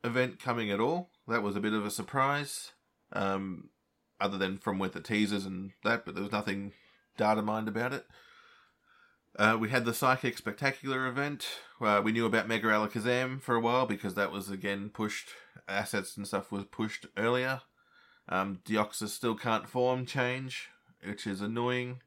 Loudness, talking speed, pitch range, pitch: -32 LUFS, 175 wpm, 100-125 Hz, 110 Hz